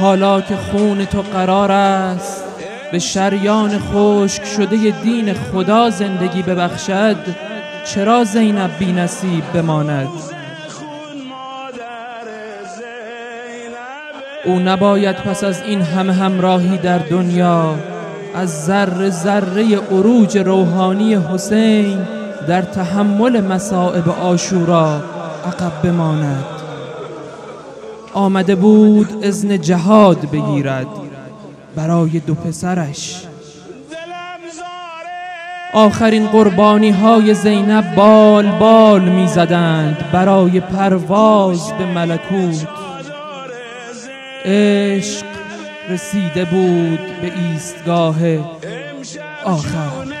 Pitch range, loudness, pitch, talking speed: 175-215 Hz, -14 LUFS, 195 Hz, 80 wpm